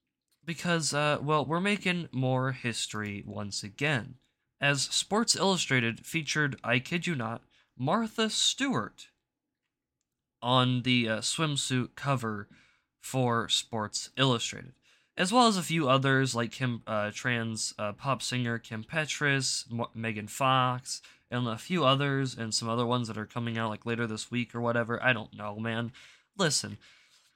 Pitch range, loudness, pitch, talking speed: 115-145 Hz, -29 LUFS, 125 Hz, 150 wpm